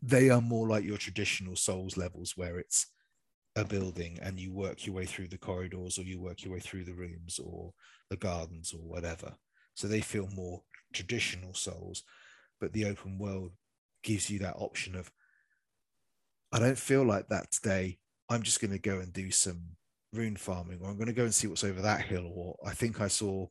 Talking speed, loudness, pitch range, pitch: 205 wpm, -34 LUFS, 90-105 Hz, 95 Hz